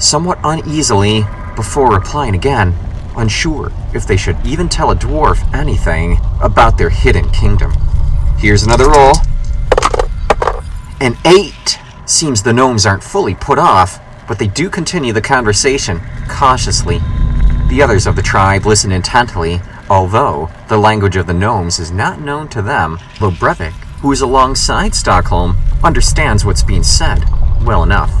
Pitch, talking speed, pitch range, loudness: 105 Hz, 145 wpm, 90-125 Hz, -12 LUFS